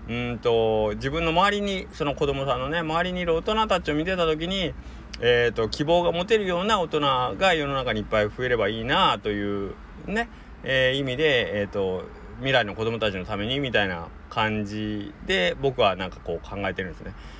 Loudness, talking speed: -24 LUFS, 375 characters per minute